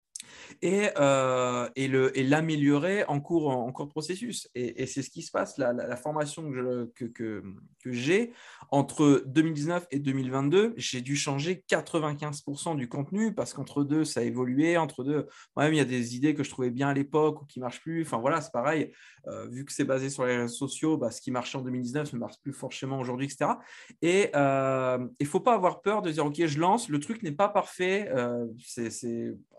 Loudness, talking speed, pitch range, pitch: -29 LUFS, 220 wpm, 125-155 Hz, 140 Hz